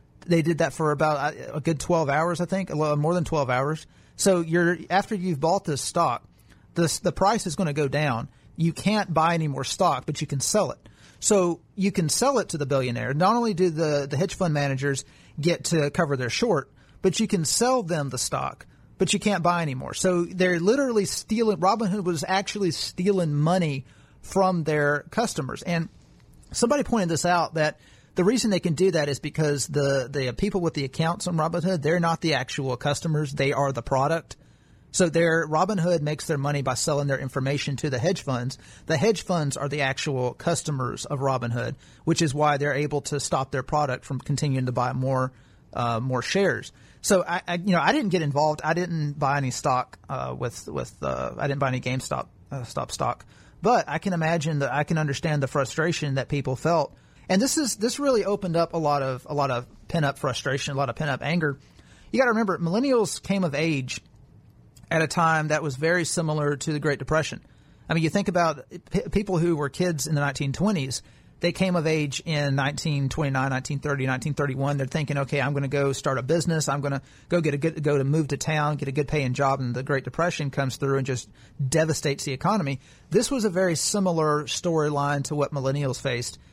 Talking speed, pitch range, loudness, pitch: 210 wpm, 140-175 Hz, -25 LUFS, 150 Hz